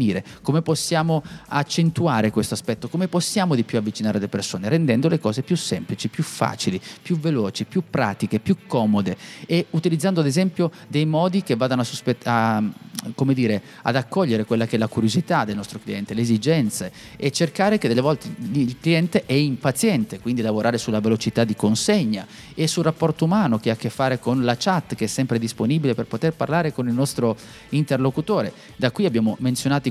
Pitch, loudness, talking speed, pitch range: 135 Hz, -22 LUFS, 185 wpm, 115-170 Hz